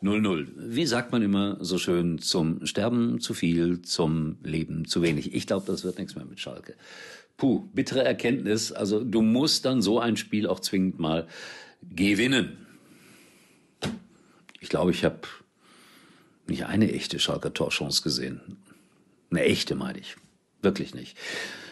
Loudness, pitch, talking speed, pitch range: -27 LUFS, 90 Hz, 145 wpm, 80-105 Hz